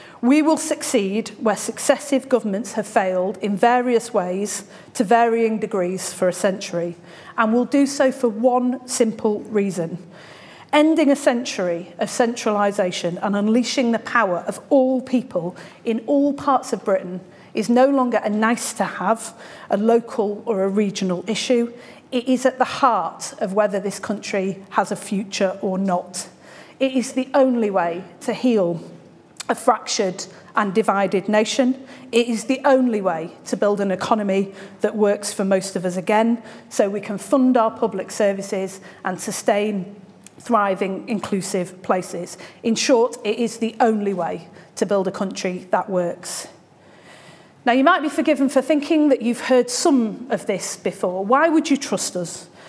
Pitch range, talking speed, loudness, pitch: 195-245 Hz, 160 wpm, -20 LUFS, 215 Hz